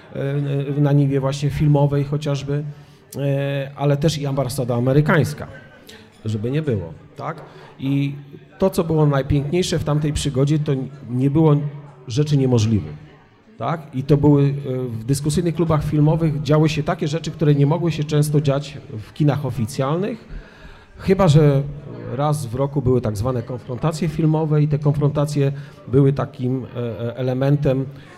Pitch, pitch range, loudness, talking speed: 145 Hz, 135-150 Hz, -20 LUFS, 135 wpm